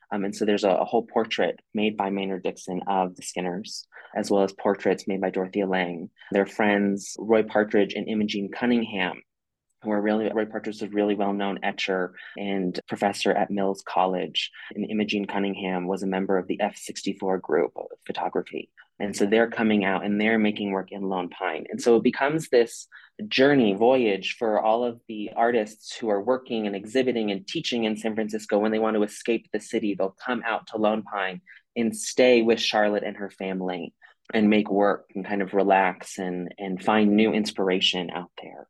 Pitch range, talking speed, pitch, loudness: 95-110 Hz, 190 wpm, 105 Hz, -25 LUFS